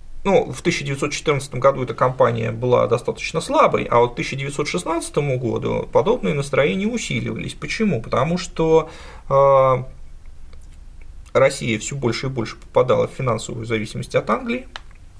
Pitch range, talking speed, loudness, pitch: 115-160 Hz, 120 wpm, -20 LUFS, 135 Hz